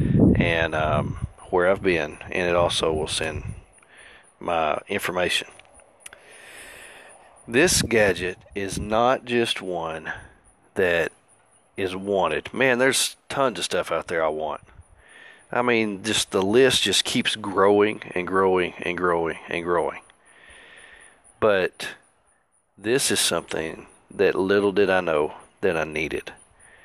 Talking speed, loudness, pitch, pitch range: 125 wpm, -23 LUFS, 95 Hz, 90-115 Hz